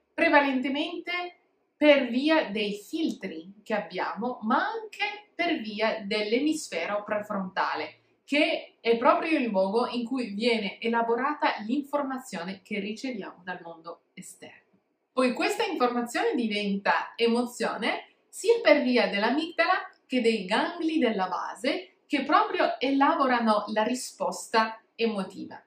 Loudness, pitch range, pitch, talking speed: -27 LUFS, 215-315 Hz, 250 Hz, 110 wpm